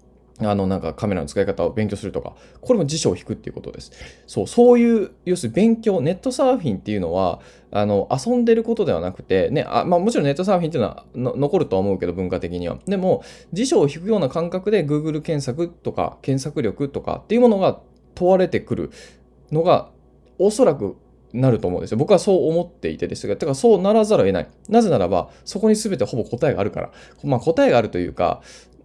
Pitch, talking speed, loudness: 170 Hz, 440 characters per minute, -20 LUFS